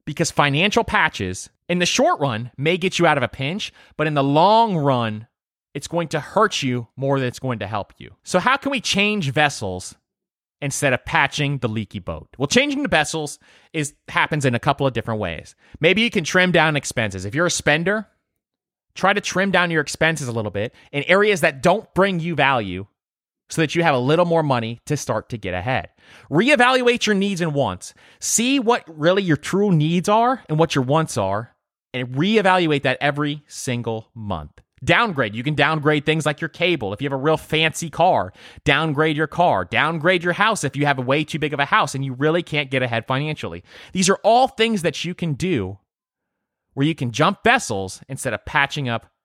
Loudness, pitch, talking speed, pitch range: -20 LUFS, 150 Hz, 210 wpm, 125-175 Hz